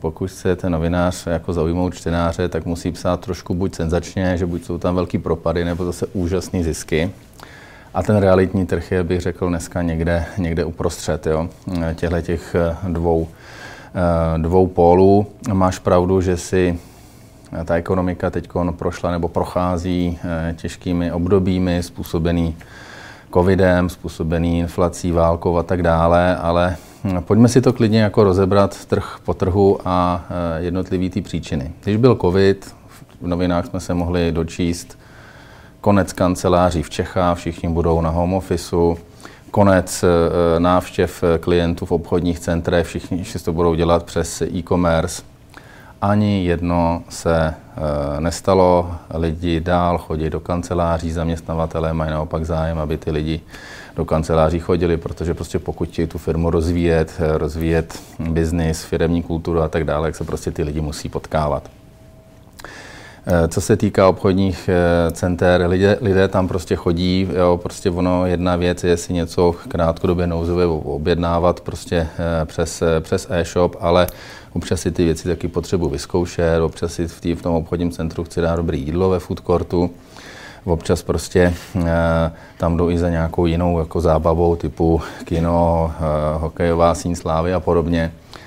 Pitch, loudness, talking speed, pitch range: 85 Hz, -19 LUFS, 140 wpm, 85-90 Hz